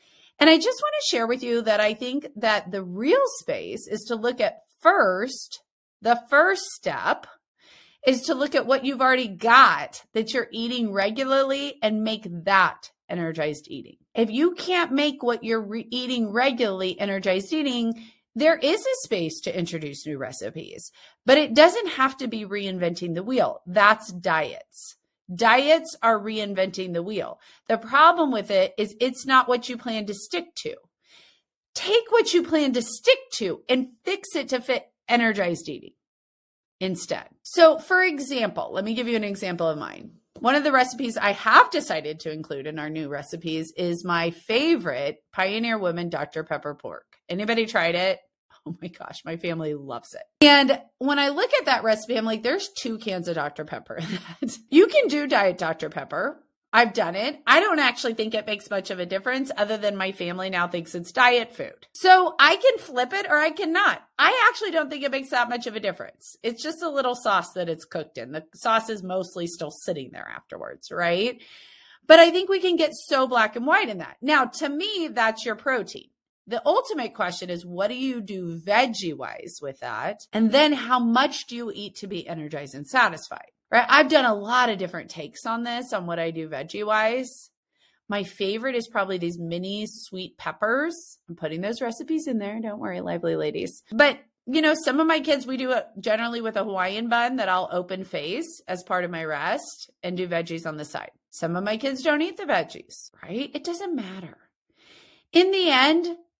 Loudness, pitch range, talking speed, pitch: -23 LUFS, 185-290 Hz, 195 wpm, 230 Hz